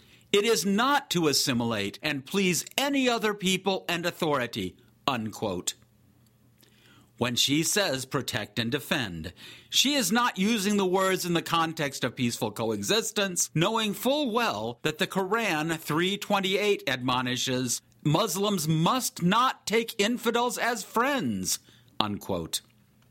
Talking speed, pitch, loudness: 120 wpm, 165 Hz, -27 LUFS